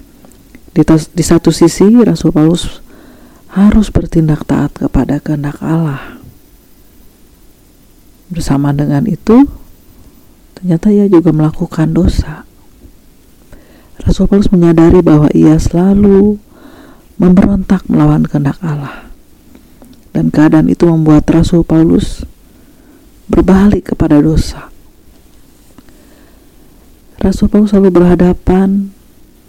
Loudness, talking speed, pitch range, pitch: -9 LUFS, 85 wpm, 155-195 Hz, 170 Hz